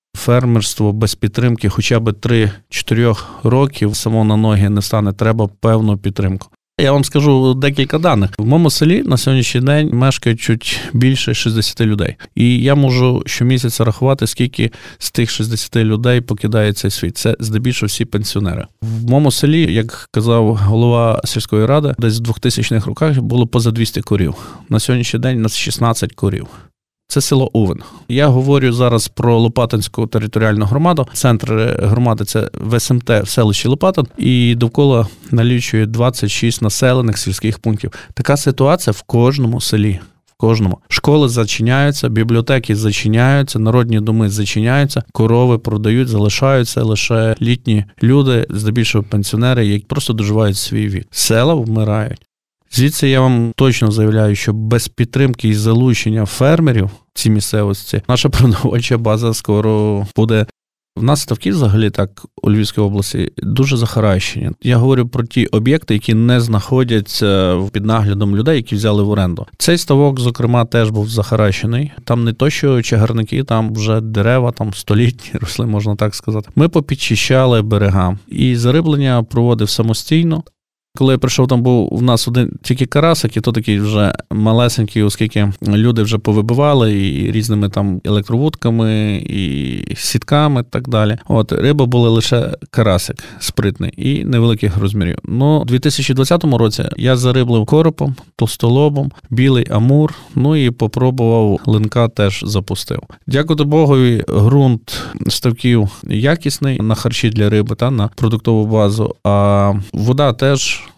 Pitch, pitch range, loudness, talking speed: 115 Hz, 105-130 Hz, -14 LUFS, 140 wpm